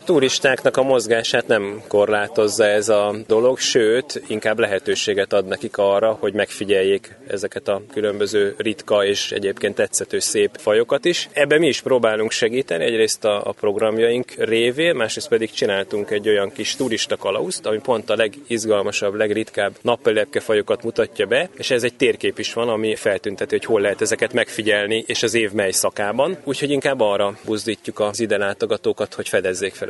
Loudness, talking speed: -19 LUFS, 160 wpm